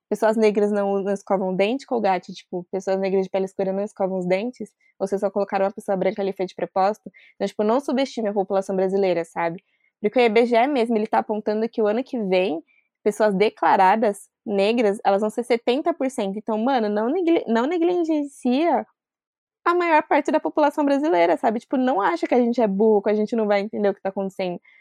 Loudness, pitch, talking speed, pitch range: -22 LUFS, 215 Hz, 210 wpm, 195-250 Hz